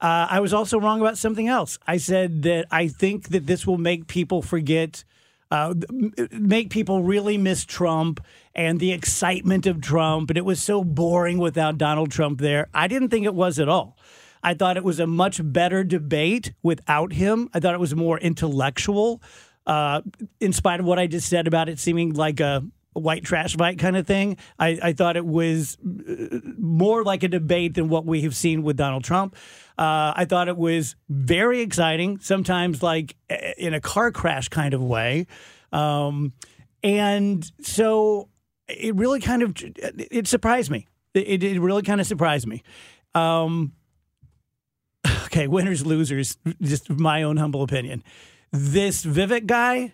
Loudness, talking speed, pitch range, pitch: -22 LUFS, 170 wpm, 155-195 Hz, 170 Hz